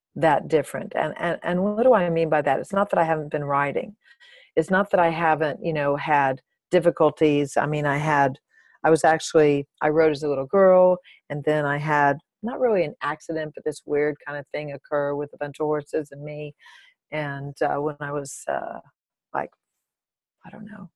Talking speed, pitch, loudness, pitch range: 205 wpm, 150 Hz, -23 LUFS, 145-170 Hz